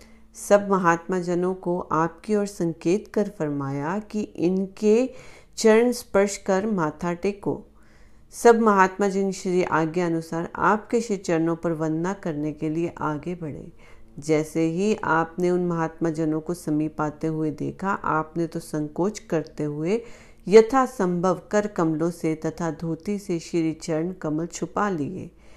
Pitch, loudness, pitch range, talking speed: 175 Hz, -24 LUFS, 160-200 Hz, 140 wpm